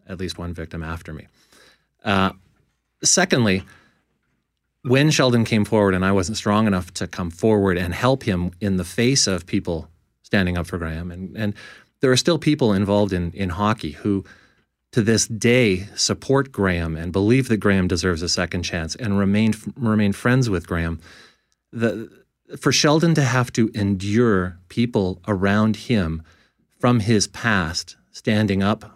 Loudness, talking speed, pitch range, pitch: -20 LUFS, 160 wpm, 90-115 Hz, 100 Hz